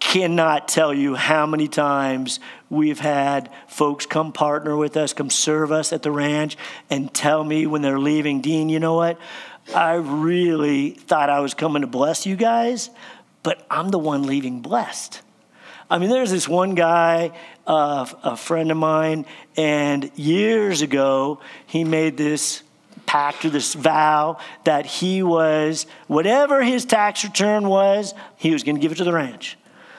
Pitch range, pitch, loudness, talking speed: 145-170 Hz, 155 Hz, -20 LUFS, 170 wpm